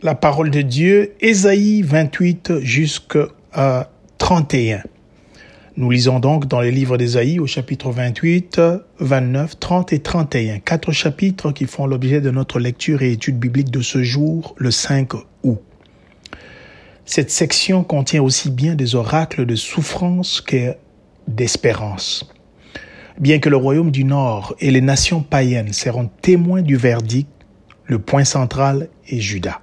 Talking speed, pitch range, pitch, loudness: 140 wpm, 125-160 Hz, 135 Hz, -17 LUFS